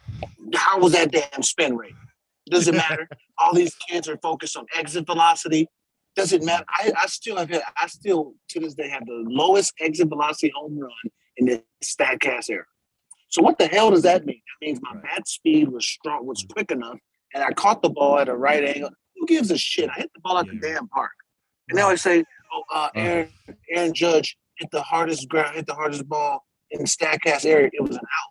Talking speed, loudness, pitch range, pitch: 225 wpm, -22 LUFS, 150-180 Hz, 165 Hz